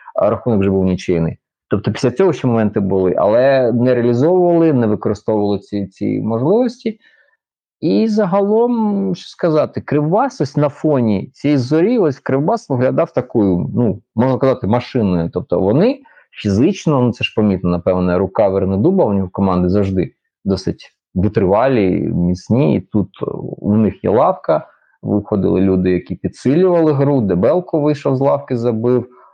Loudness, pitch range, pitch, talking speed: -16 LUFS, 100-150 Hz, 120 Hz, 145 wpm